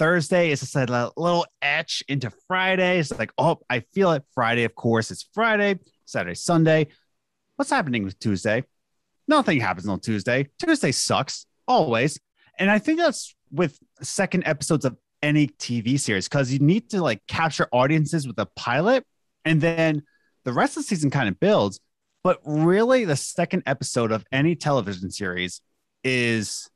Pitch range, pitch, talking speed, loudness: 120-180 Hz, 150 Hz, 165 wpm, -23 LUFS